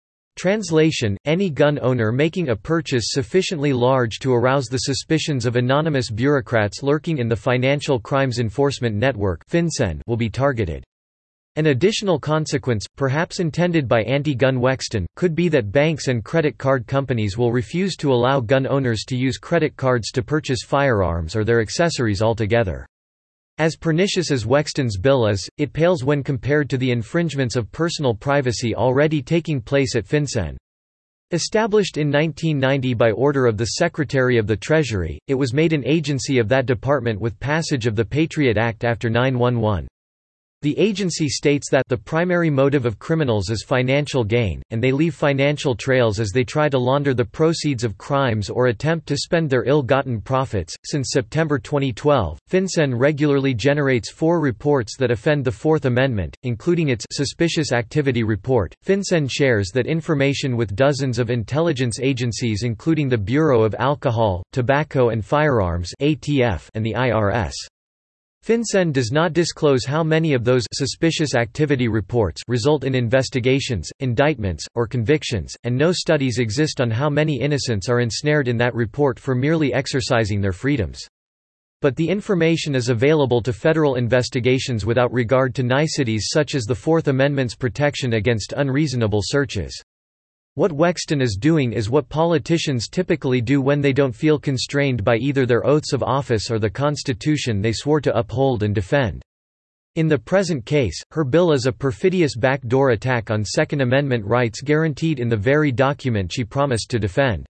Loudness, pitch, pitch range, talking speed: -20 LUFS, 135 Hz, 115-150 Hz, 160 wpm